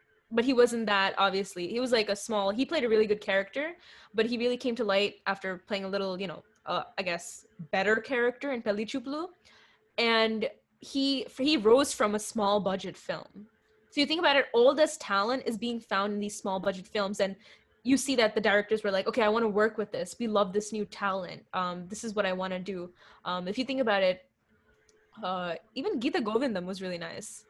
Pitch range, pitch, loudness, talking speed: 195-240 Hz, 210 Hz, -29 LUFS, 225 wpm